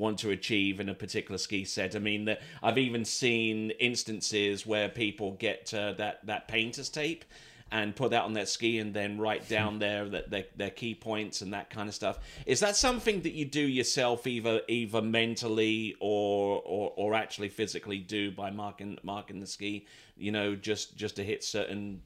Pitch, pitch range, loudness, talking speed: 105 Hz, 100-115 Hz, -32 LUFS, 195 wpm